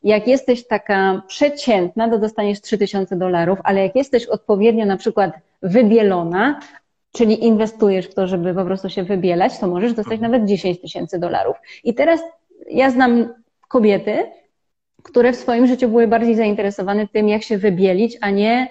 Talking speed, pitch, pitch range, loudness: 160 wpm, 215 Hz, 195-240 Hz, -17 LUFS